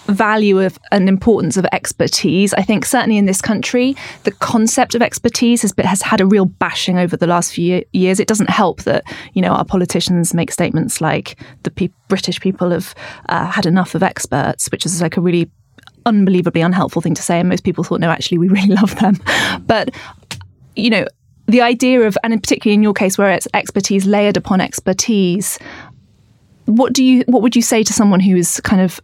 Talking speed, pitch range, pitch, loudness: 205 wpm, 175-220 Hz, 195 Hz, -14 LUFS